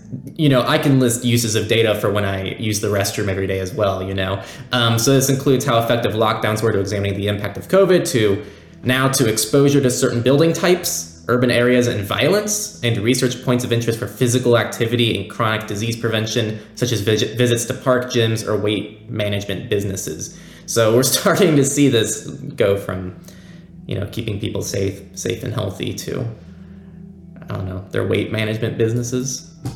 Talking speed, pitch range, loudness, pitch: 185 wpm, 100-125 Hz, -18 LUFS, 115 Hz